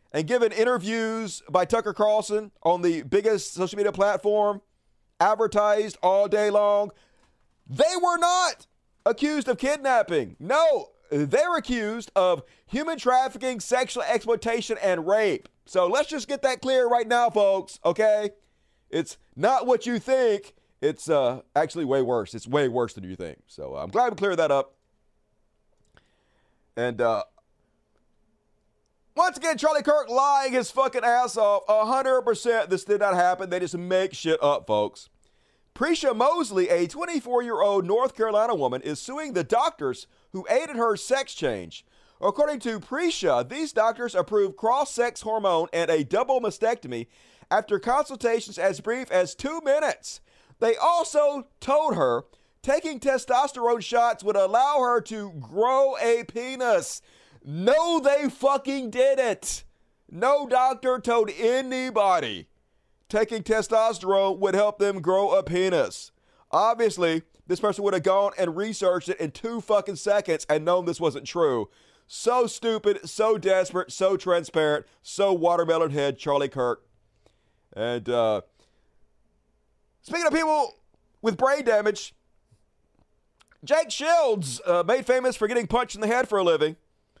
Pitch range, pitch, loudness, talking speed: 185-260 Hz, 220 Hz, -24 LUFS, 140 wpm